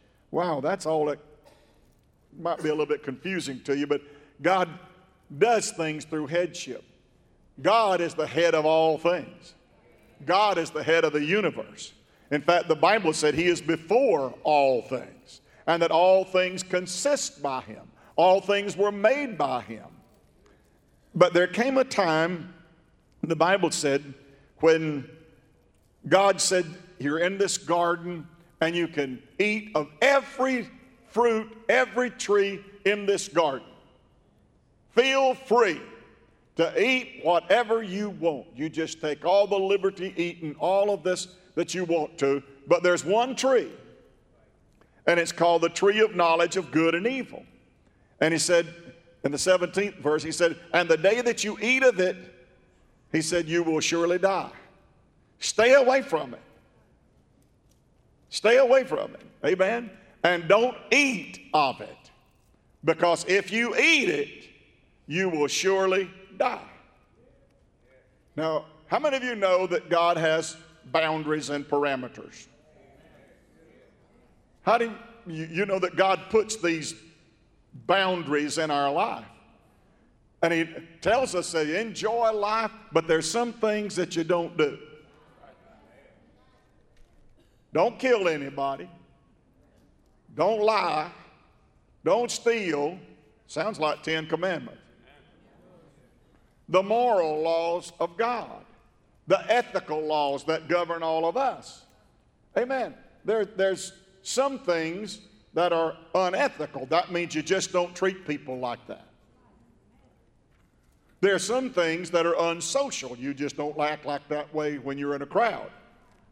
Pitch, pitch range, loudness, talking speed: 175 Hz, 160-200 Hz, -25 LUFS, 135 wpm